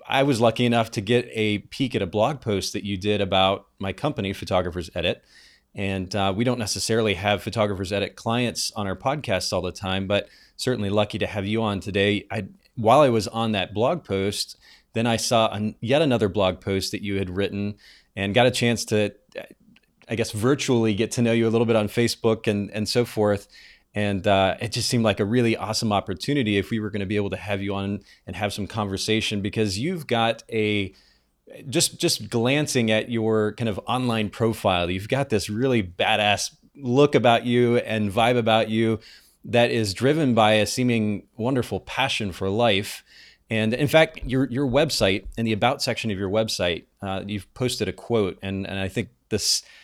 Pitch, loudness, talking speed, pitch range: 110 Hz, -23 LUFS, 200 wpm, 100-120 Hz